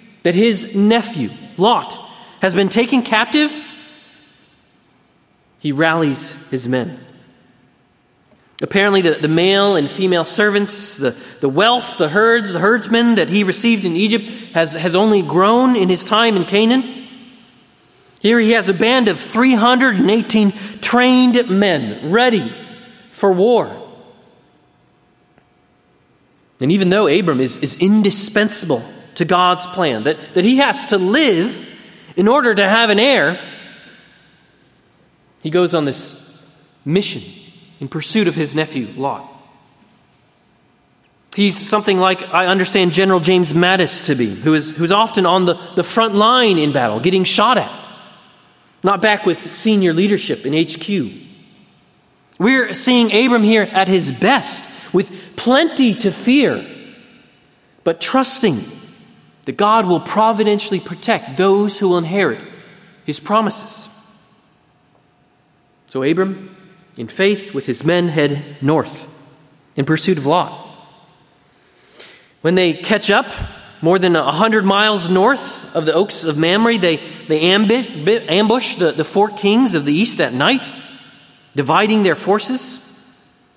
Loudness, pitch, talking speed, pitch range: -15 LUFS, 195 Hz, 130 wpm, 165-220 Hz